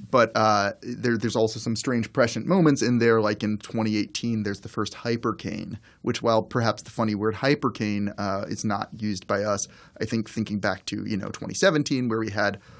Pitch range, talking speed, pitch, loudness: 105-115 Hz, 195 wpm, 110 Hz, -25 LUFS